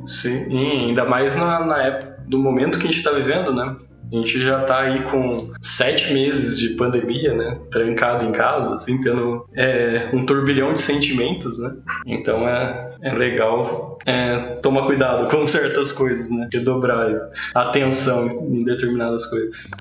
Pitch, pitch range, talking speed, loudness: 125 Hz, 120-135 Hz, 165 wpm, -20 LUFS